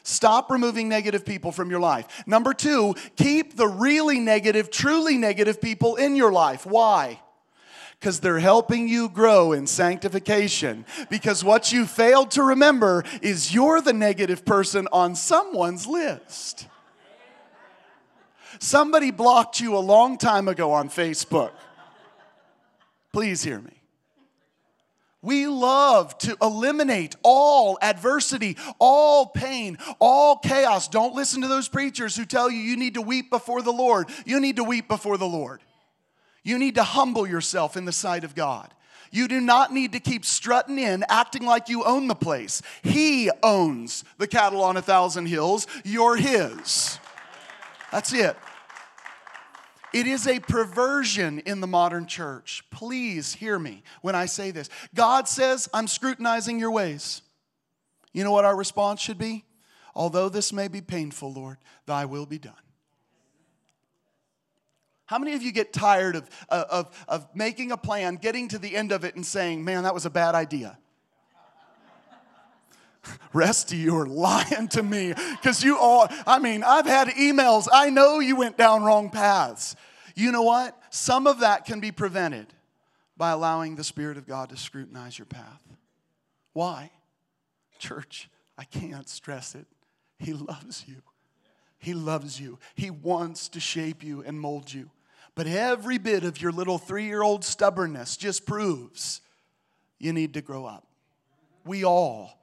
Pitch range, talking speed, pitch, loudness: 170-245 Hz, 150 wpm, 205 Hz, -22 LUFS